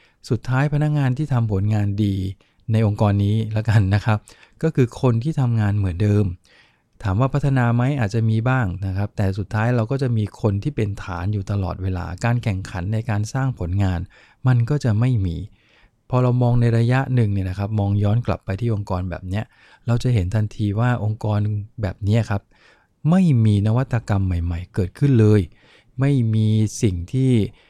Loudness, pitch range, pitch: -21 LUFS, 100-120 Hz, 110 Hz